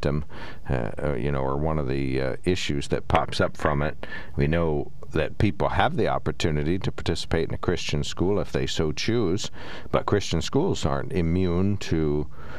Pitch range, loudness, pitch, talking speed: 70-85 Hz, -26 LUFS, 75 Hz, 175 wpm